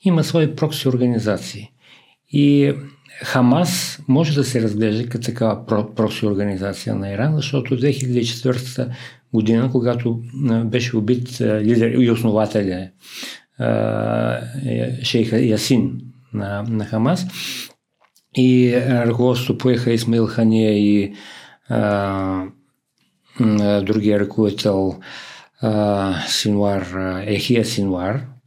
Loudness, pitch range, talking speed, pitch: -19 LUFS, 105-125 Hz, 80 wpm, 115 Hz